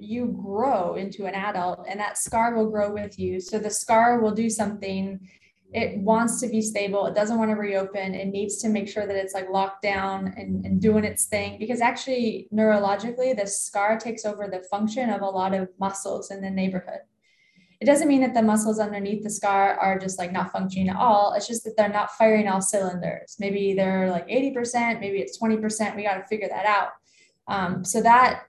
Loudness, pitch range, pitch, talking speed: -24 LUFS, 195-220 Hz, 205 Hz, 210 wpm